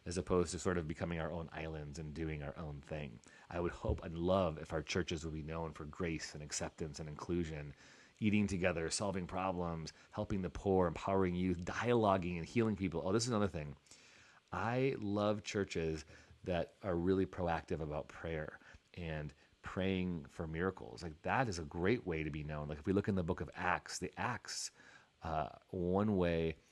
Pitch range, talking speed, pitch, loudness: 80-95 Hz, 190 wpm, 85 Hz, -39 LUFS